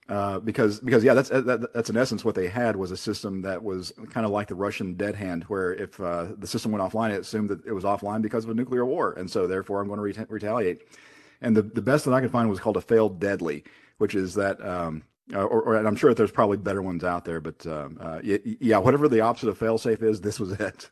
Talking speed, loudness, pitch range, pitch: 265 wpm, -26 LUFS, 95-115 Hz, 105 Hz